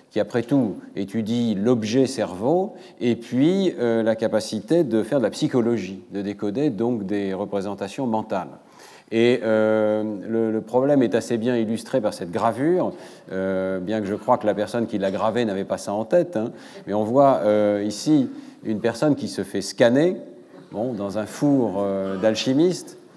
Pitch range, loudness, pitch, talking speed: 105-125 Hz, -22 LUFS, 110 Hz, 175 wpm